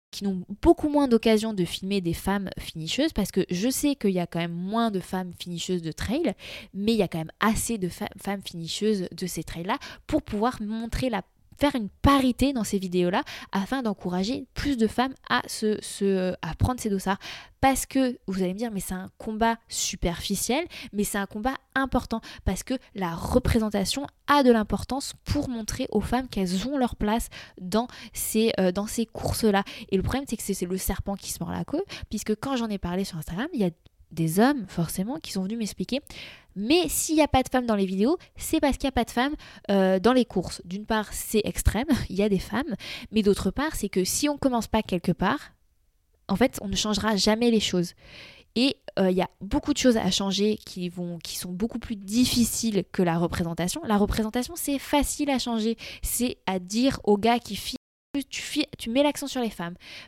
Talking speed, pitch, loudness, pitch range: 220 wpm, 215 Hz, -26 LUFS, 190-255 Hz